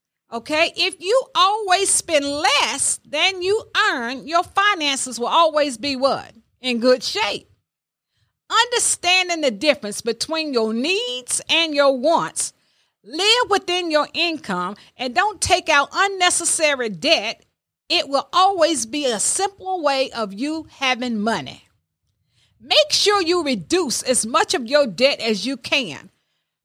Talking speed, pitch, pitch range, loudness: 135 wpm, 305 Hz, 255-360 Hz, -19 LUFS